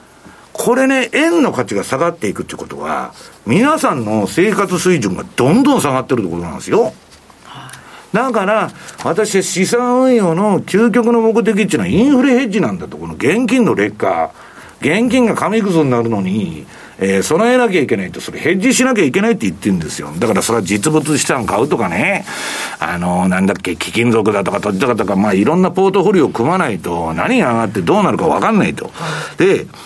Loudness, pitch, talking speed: -14 LUFS, 190 Hz, 400 characters per minute